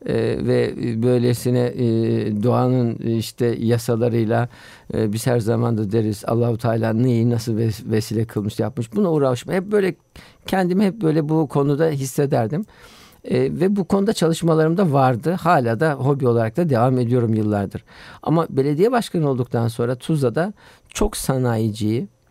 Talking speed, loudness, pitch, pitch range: 145 wpm, -20 LUFS, 125 Hz, 115-155 Hz